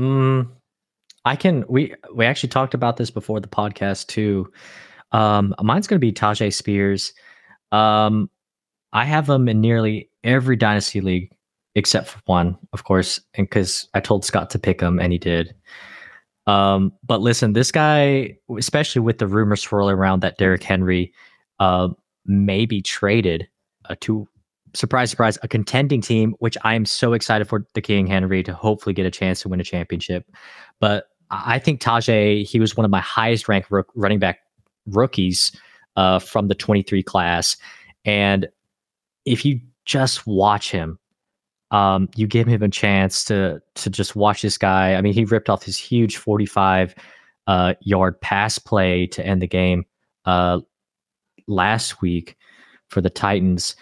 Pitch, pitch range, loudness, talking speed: 105 Hz, 95-115 Hz, -19 LUFS, 165 wpm